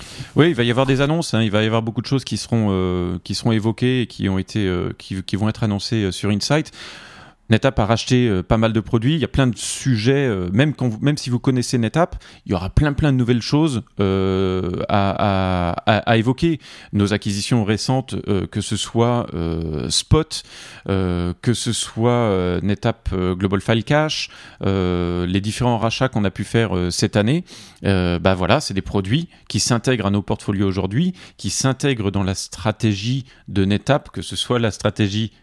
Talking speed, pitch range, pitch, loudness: 205 wpm, 95-125 Hz, 110 Hz, -20 LUFS